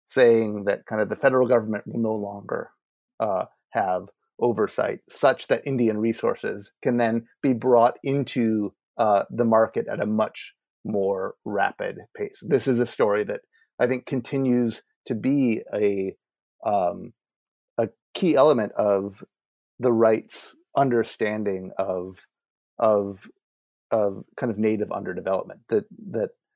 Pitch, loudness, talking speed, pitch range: 115 Hz, -24 LUFS, 135 wpm, 105-130 Hz